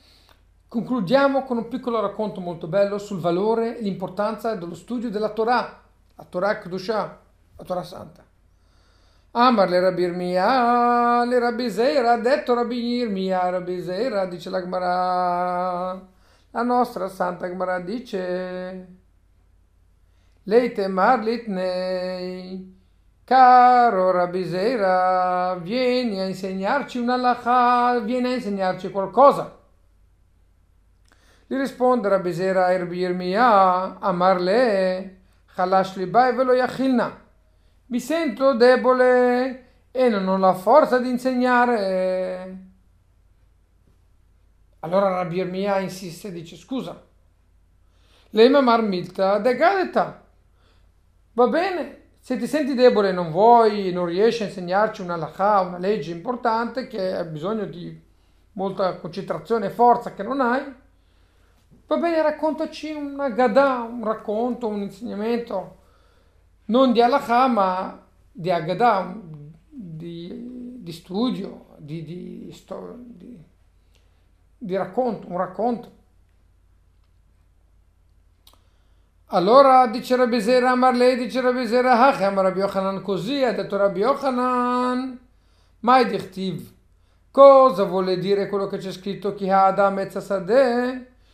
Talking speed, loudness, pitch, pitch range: 110 wpm, -21 LUFS, 195 Hz, 180-245 Hz